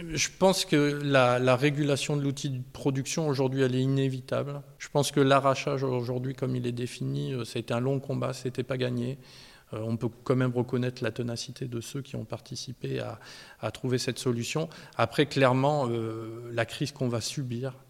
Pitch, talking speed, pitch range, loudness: 130 Hz, 190 wpm, 125-140 Hz, -29 LUFS